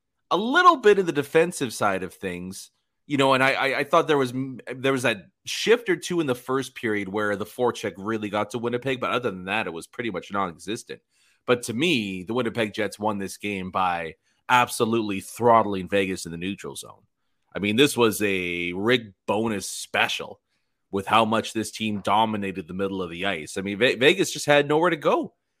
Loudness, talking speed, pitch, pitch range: -24 LUFS, 210 wpm, 110 Hz, 100-130 Hz